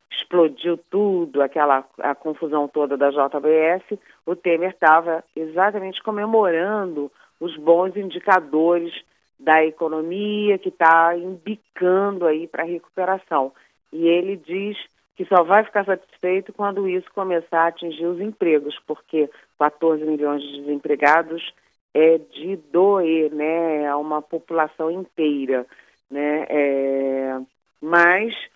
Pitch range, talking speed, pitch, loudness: 150-185 Hz, 115 wpm, 165 Hz, -20 LUFS